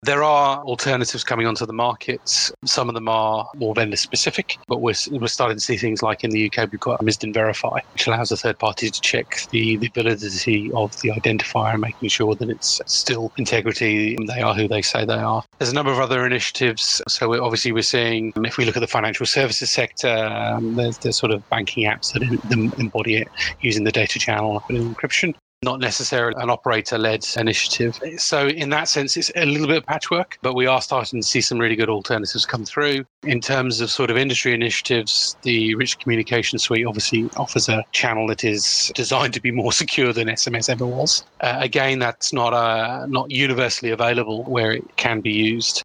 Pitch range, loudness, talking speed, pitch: 110-125 Hz, -20 LUFS, 210 wpm, 115 Hz